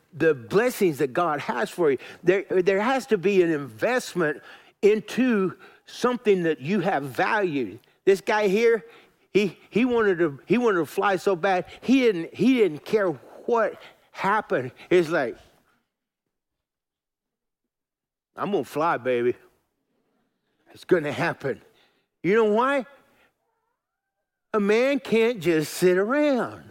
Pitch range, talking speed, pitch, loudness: 175-245 Hz, 135 wpm, 205 Hz, -24 LUFS